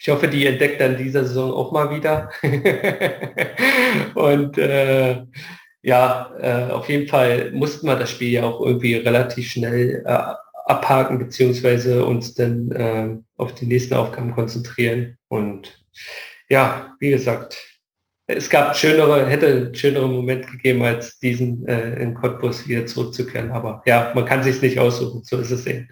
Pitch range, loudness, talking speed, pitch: 120-135 Hz, -19 LUFS, 155 wpm, 125 Hz